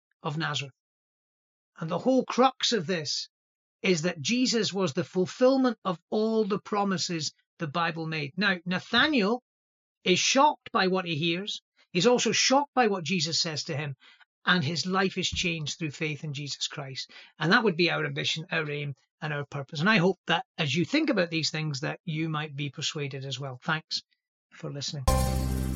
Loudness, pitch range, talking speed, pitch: -27 LUFS, 155-200 Hz, 185 wpm, 170 Hz